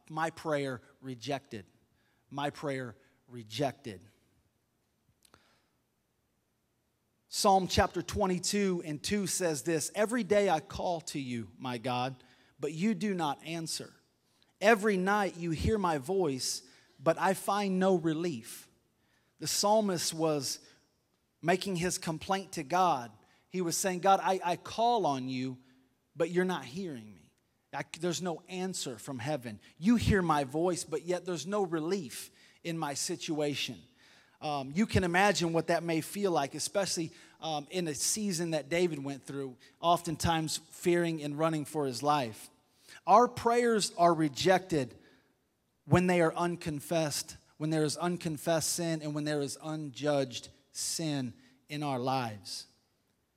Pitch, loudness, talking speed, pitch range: 155 Hz, -32 LUFS, 140 wpm, 135-180 Hz